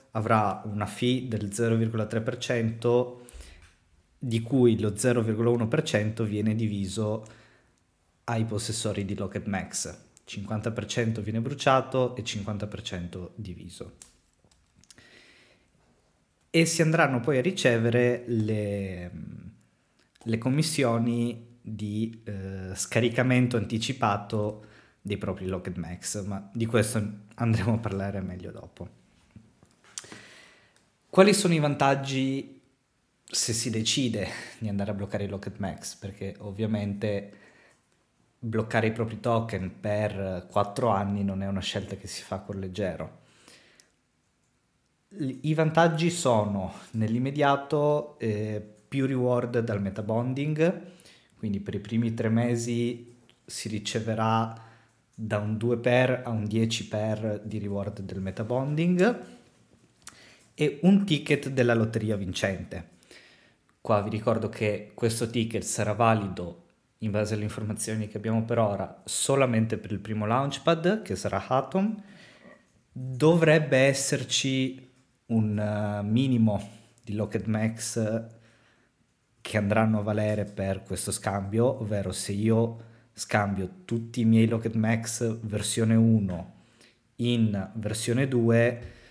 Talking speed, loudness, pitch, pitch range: 110 wpm, -27 LUFS, 110 Hz, 105-120 Hz